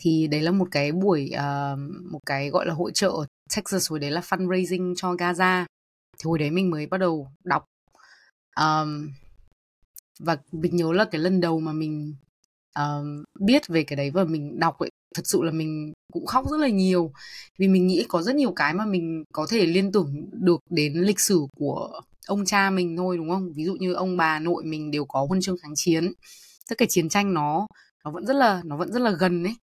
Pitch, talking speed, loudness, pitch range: 175 Hz, 220 wpm, -24 LUFS, 155-185 Hz